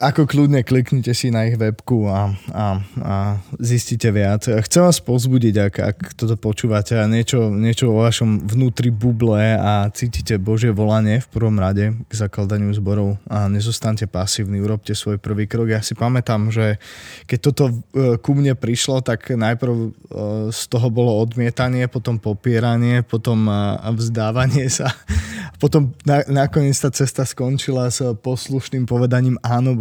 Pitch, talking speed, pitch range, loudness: 115 Hz, 145 wpm, 105-125 Hz, -18 LUFS